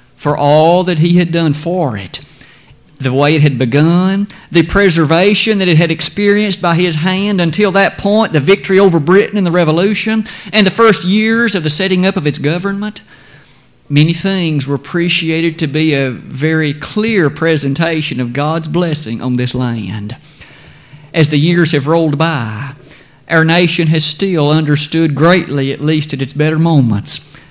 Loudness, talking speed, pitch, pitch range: -12 LUFS, 170 wpm, 160 Hz, 145-185 Hz